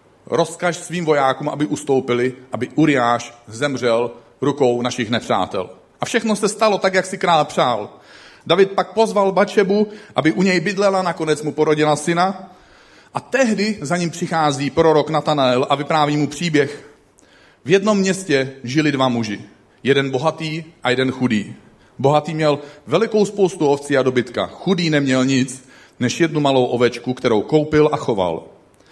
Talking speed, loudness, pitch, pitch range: 150 wpm, -18 LUFS, 150 Hz, 130-175 Hz